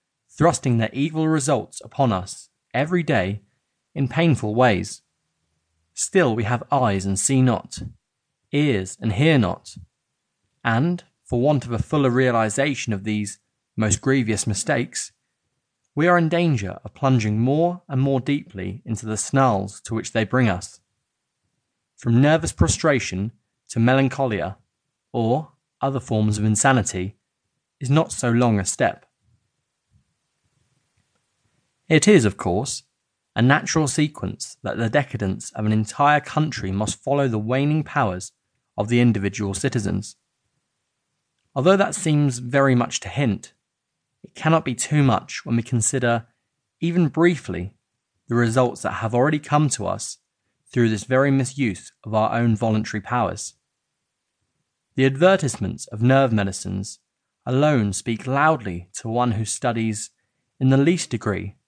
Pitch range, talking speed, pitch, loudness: 105-140 Hz, 135 wpm, 120 Hz, -21 LUFS